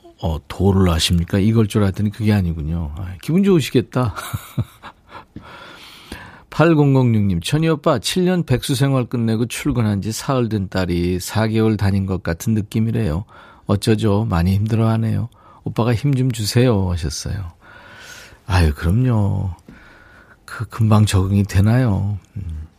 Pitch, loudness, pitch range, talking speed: 105 Hz, -18 LUFS, 95-120 Hz, 260 characters per minute